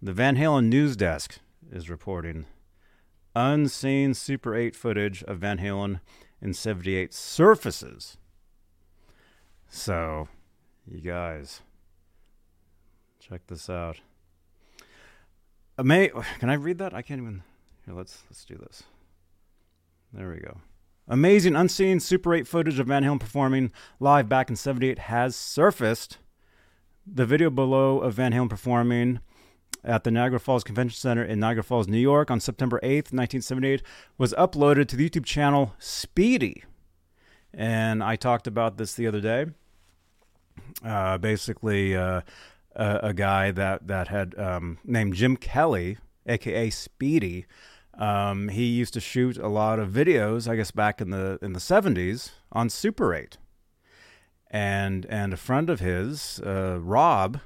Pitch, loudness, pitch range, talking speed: 105 Hz, -25 LUFS, 90-125 Hz, 140 wpm